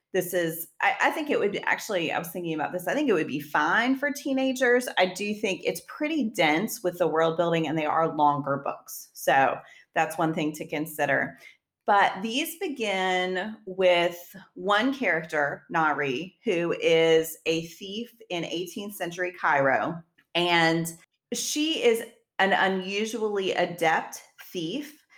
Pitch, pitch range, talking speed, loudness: 180 Hz, 165-225 Hz, 155 wpm, -26 LUFS